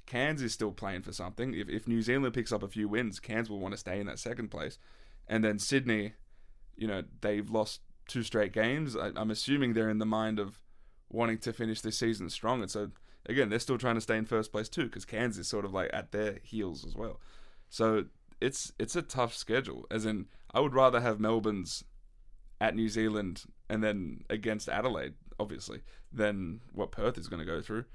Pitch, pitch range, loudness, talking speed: 110 Hz, 105-115 Hz, -34 LUFS, 215 wpm